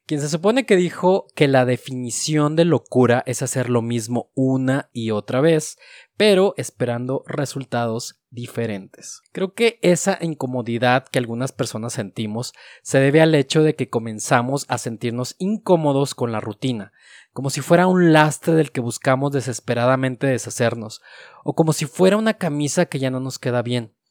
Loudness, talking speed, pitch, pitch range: -20 LUFS, 160 wpm, 130 Hz, 120-160 Hz